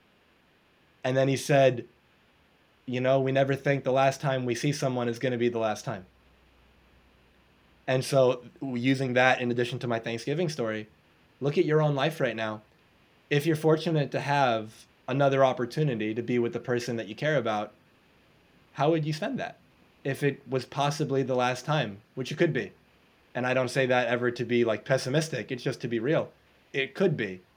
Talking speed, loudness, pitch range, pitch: 195 wpm, -28 LUFS, 120-140 Hz, 130 Hz